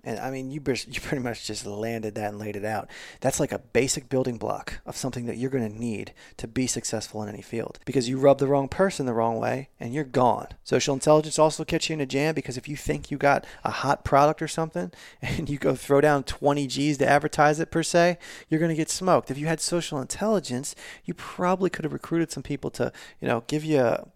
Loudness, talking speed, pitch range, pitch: -26 LUFS, 255 wpm, 125-155 Hz, 140 Hz